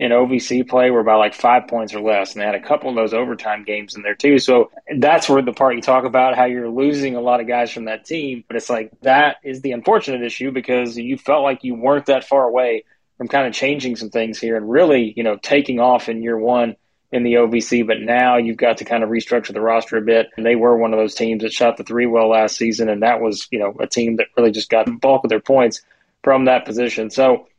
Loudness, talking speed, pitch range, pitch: -17 LUFS, 265 wpm, 115-130 Hz, 120 Hz